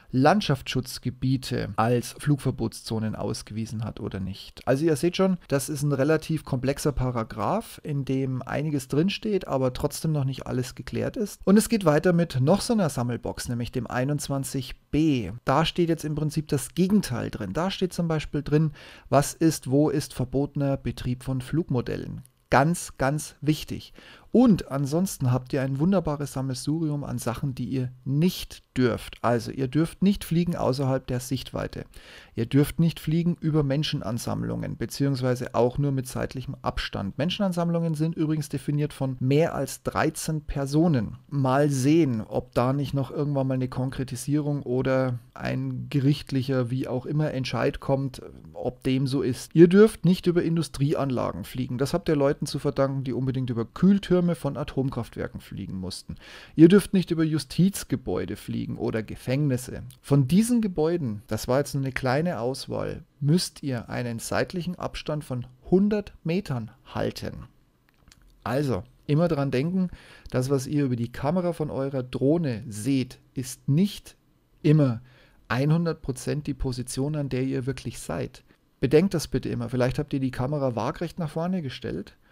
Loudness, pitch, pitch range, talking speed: -26 LUFS, 140 Hz, 125-155 Hz, 155 wpm